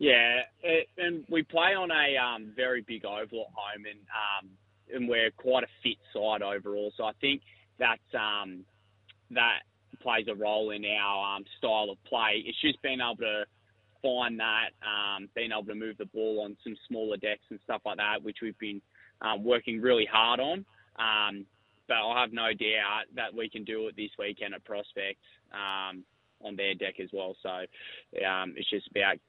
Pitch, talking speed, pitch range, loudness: 105 Hz, 190 wpm, 100-115 Hz, -30 LUFS